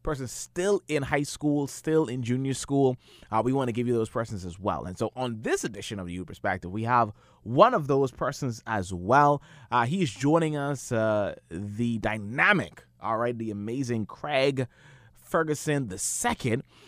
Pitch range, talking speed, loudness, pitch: 110-145 Hz, 180 wpm, -27 LUFS, 125 Hz